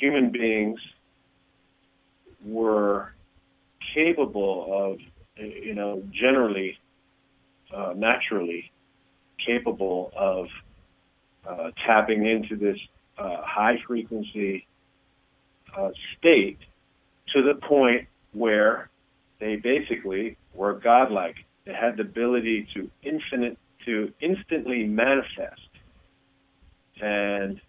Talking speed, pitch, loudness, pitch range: 80 wpm, 105 Hz, -25 LUFS, 100-120 Hz